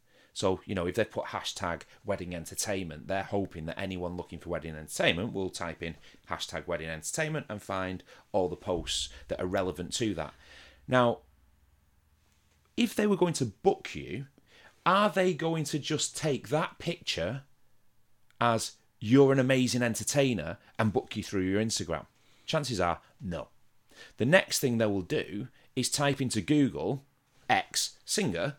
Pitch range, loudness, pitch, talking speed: 85-135 Hz, -30 LUFS, 105 Hz, 155 wpm